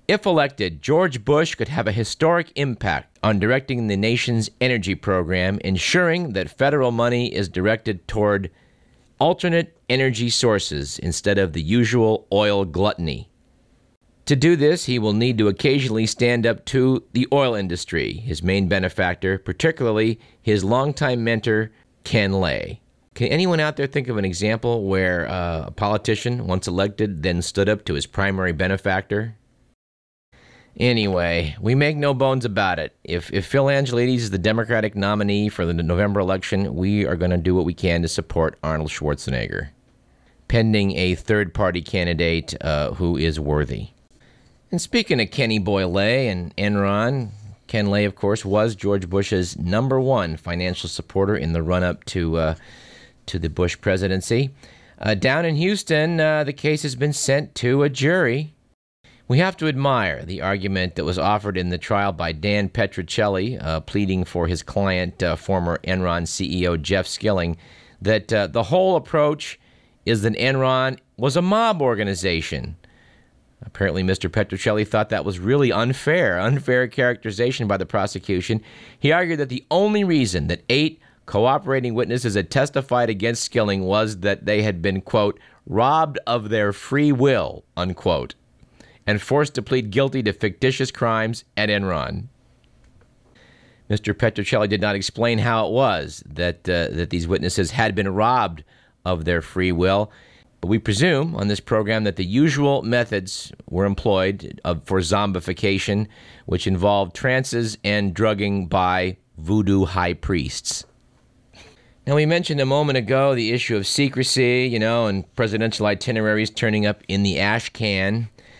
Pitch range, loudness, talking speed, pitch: 95-125 Hz, -21 LUFS, 155 wpm, 105 Hz